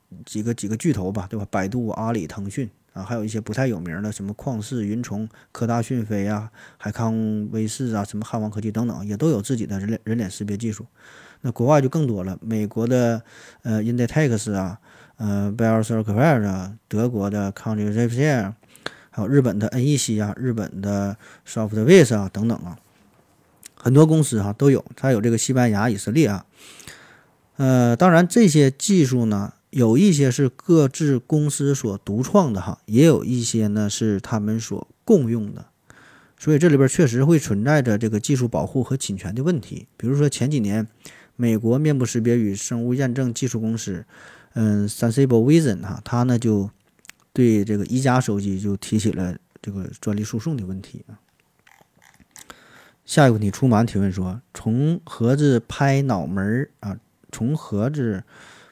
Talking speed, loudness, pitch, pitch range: 290 characters per minute, -21 LUFS, 115 Hz, 105-130 Hz